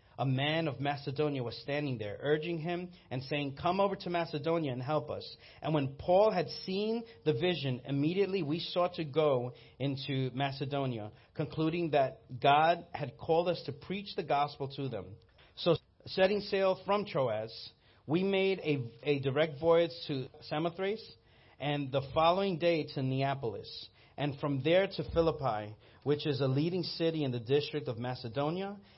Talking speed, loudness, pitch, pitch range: 160 wpm, -33 LUFS, 150 Hz, 135-170 Hz